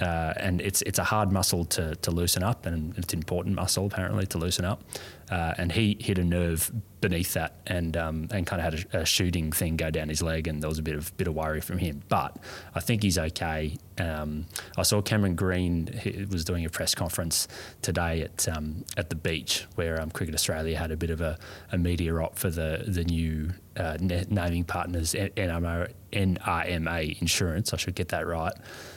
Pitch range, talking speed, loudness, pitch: 80-95 Hz, 205 wpm, -28 LUFS, 85 Hz